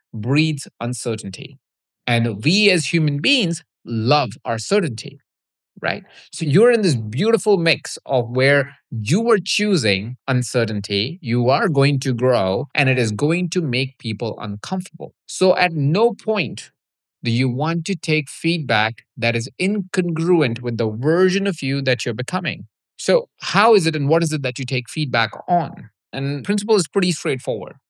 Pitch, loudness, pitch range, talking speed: 145 Hz, -19 LUFS, 120-180 Hz, 160 wpm